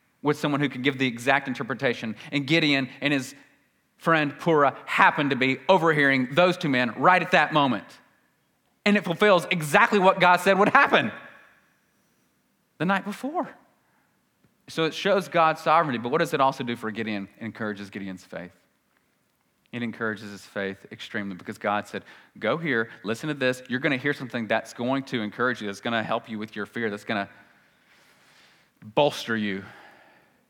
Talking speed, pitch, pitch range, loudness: 175 wpm, 135 Hz, 110-165 Hz, -24 LUFS